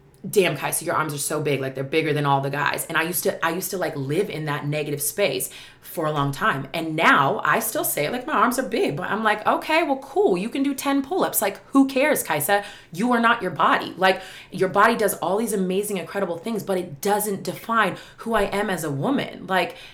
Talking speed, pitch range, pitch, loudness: 245 wpm, 155-220 Hz, 190 Hz, -22 LUFS